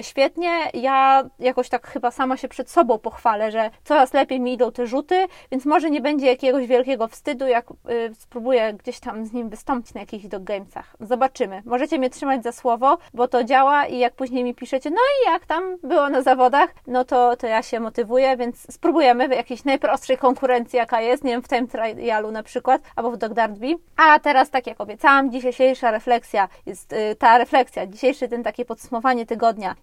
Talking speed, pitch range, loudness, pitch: 195 wpm, 235-270 Hz, -20 LUFS, 250 Hz